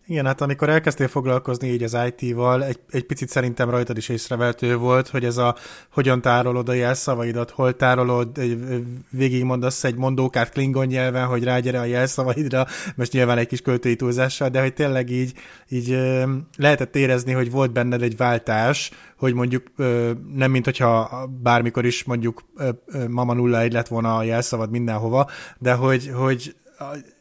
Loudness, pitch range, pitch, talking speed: -21 LUFS, 120-130 Hz, 125 Hz, 155 wpm